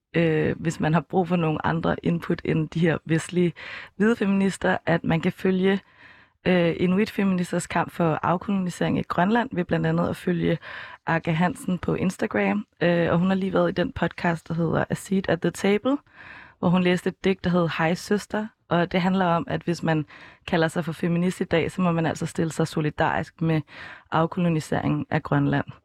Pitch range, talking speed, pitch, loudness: 160-185 Hz, 200 wpm, 175 Hz, -24 LUFS